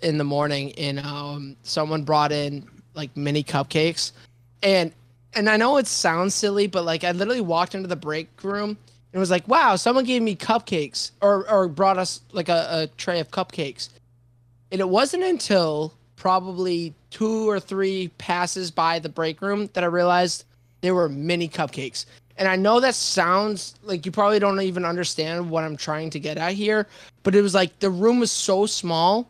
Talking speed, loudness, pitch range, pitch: 190 wpm, -22 LUFS, 150-195 Hz, 175 Hz